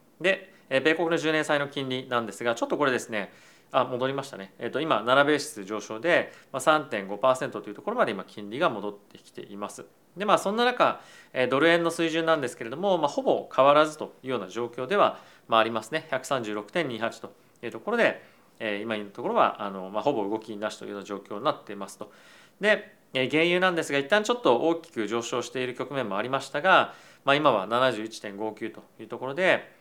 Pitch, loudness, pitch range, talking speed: 130 Hz, -26 LUFS, 110-160 Hz, 380 characters per minute